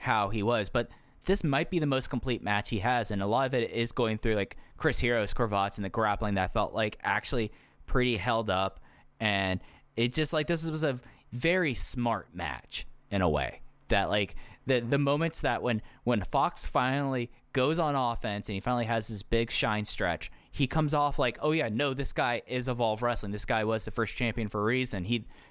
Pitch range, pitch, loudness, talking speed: 105-135 Hz, 120 Hz, -30 LUFS, 215 wpm